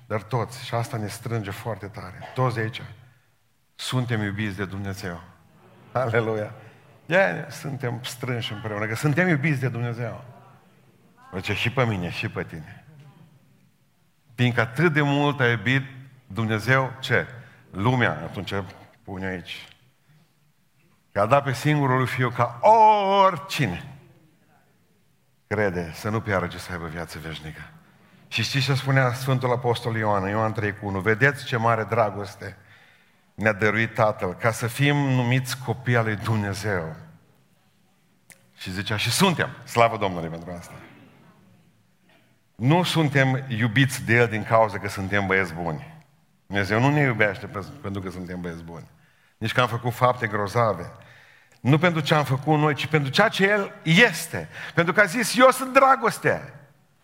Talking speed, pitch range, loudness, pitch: 145 wpm, 105-145 Hz, -23 LUFS, 120 Hz